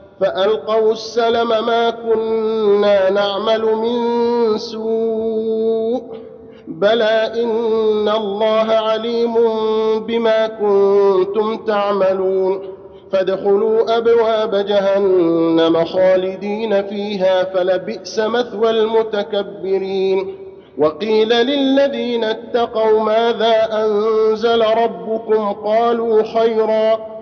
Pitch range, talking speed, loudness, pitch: 200-225 Hz, 65 wpm, -16 LUFS, 220 Hz